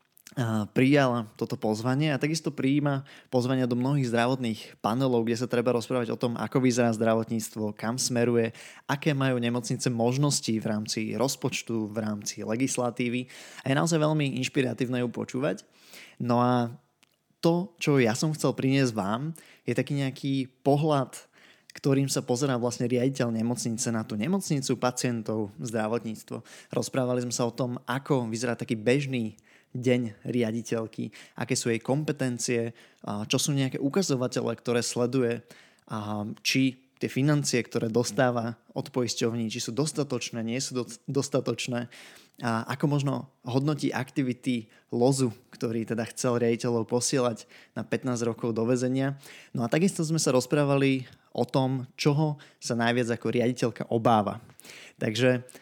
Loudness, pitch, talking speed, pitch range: -28 LUFS, 125 Hz, 135 wpm, 115-135 Hz